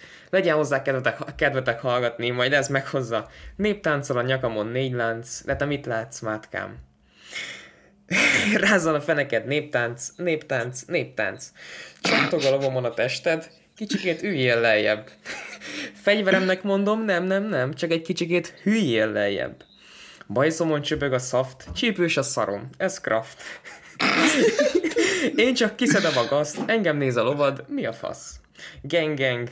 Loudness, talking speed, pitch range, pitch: -23 LUFS, 130 wpm, 125-185 Hz, 145 Hz